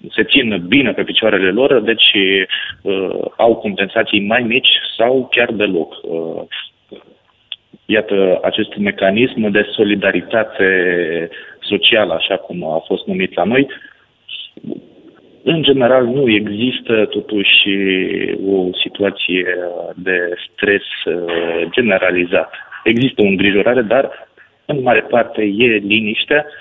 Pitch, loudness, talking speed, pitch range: 105 Hz, -14 LUFS, 110 wpm, 95-115 Hz